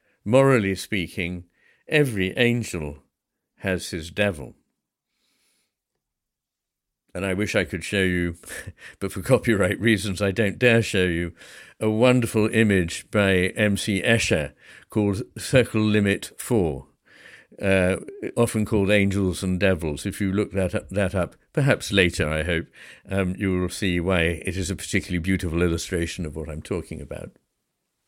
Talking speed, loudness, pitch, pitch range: 140 wpm, -23 LUFS, 95 Hz, 90-105 Hz